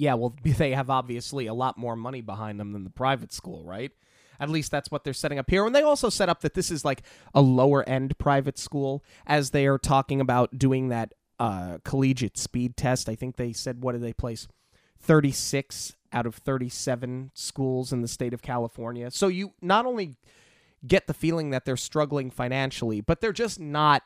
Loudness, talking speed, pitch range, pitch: -26 LUFS, 205 wpm, 120-145 Hz, 130 Hz